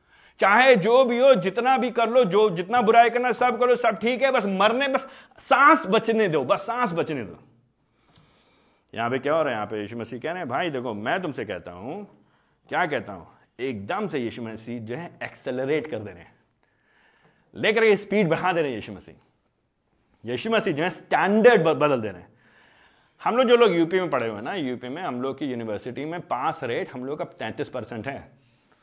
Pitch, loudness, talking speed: 195 Hz, -23 LUFS, 210 wpm